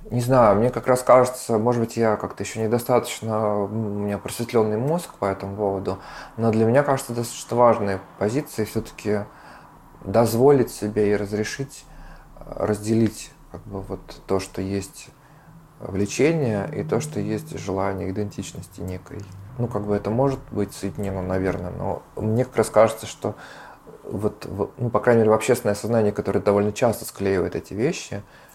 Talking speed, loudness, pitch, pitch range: 155 wpm, -23 LUFS, 110 Hz, 100-120 Hz